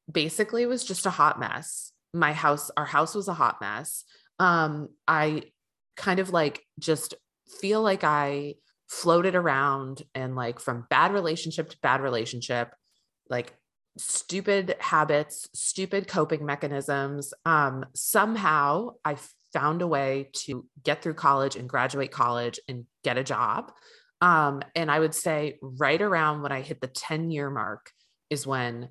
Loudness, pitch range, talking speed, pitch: -27 LUFS, 140-170 Hz, 150 wpm, 150 Hz